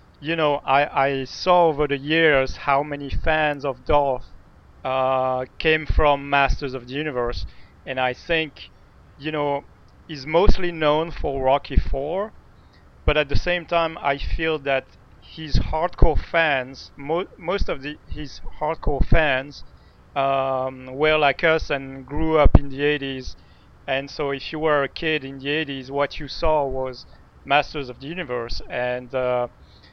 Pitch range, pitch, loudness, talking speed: 130-150 Hz, 140 Hz, -22 LUFS, 160 wpm